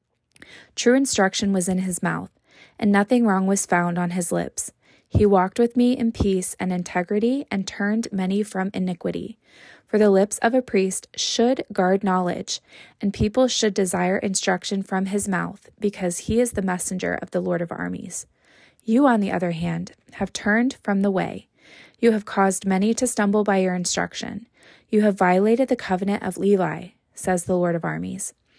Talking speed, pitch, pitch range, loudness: 180 wpm, 195 Hz, 185-215 Hz, -22 LUFS